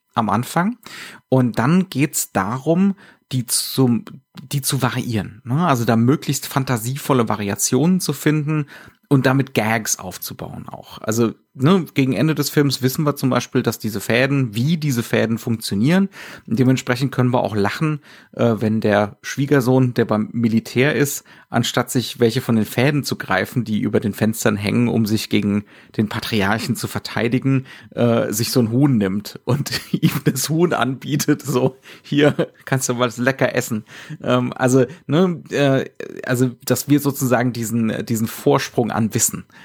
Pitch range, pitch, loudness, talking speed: 115-140 Hz, 125 Hz, -19 LUFS, 155 wpm